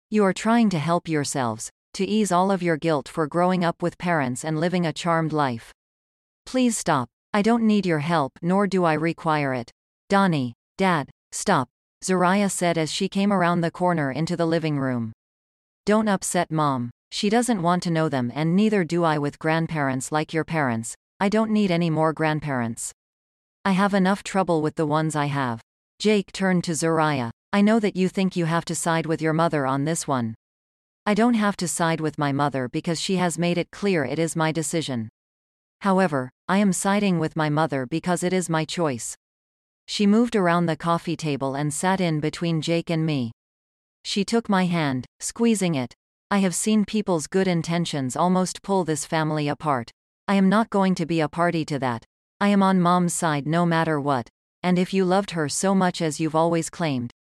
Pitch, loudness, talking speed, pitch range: 165 Hz, -23 LUFS, 200 wpm, 145-185 Hz